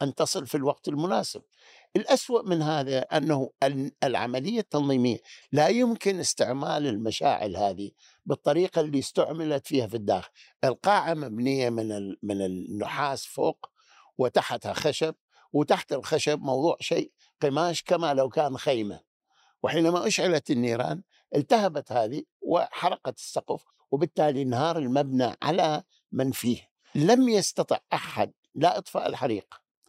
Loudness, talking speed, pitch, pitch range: -27 LUFS, 115 wpm, 145 Hz, 125-160 Hz